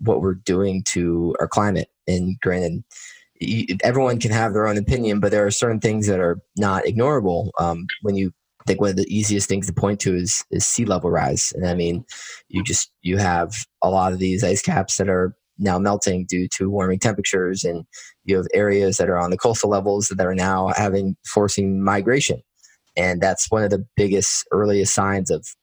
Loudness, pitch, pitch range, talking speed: -20 LUFS, 95 Hz, 90-100 Hz, 200 wpm